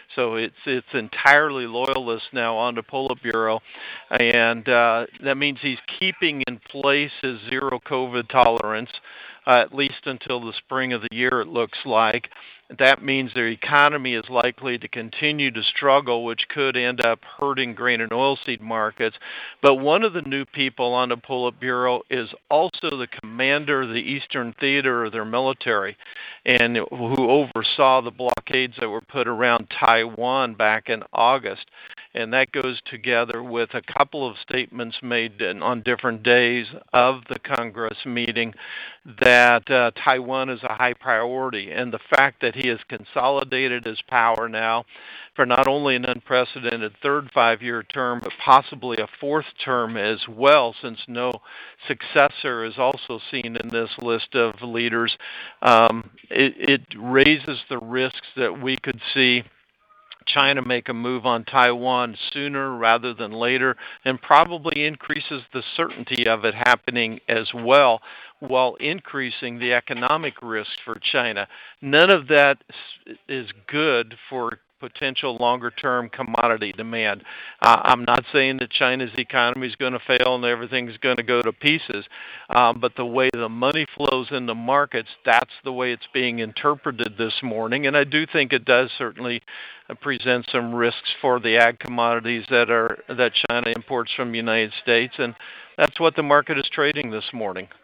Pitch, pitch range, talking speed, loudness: 125 Hz, 115-135 Hz, 160 wpm, -21 LUFS